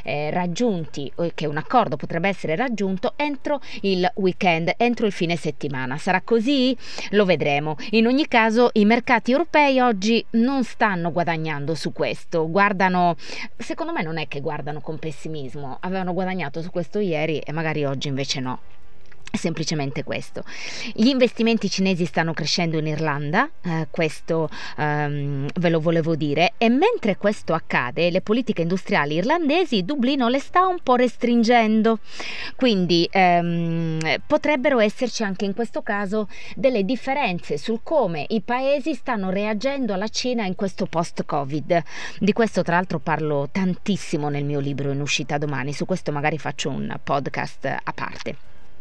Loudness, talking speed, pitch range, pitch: -22 LUFS, 150 wpm, 155-230 Hz, 185 Hz